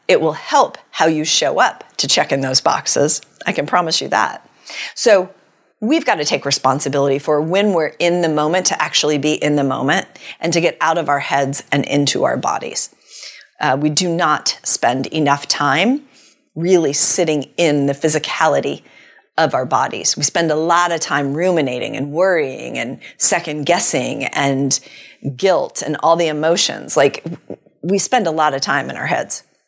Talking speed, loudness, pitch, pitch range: 180 wpm, -16 LUFS, 155 Hz, 140-175 Hz